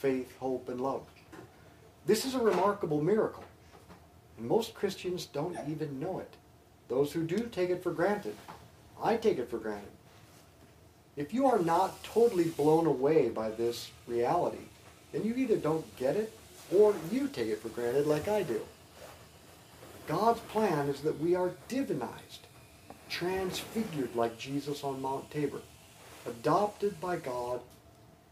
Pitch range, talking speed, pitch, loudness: 120-200 Hz, 145 wpm, 155 Hz, -32 LUFS